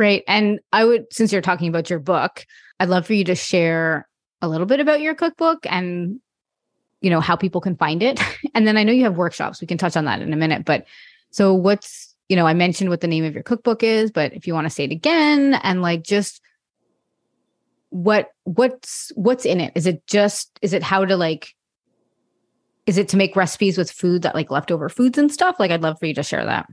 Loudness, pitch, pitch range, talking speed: -19 LUFS, 190 Hz, 170-220 Hz, 235 wpm